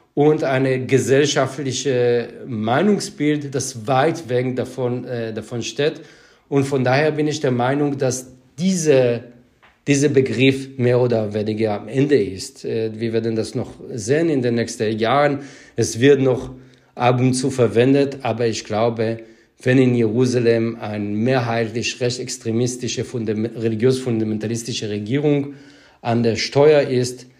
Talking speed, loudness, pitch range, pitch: 130 wpm, -19 LUFS, 115-135 Hz, 125 Hz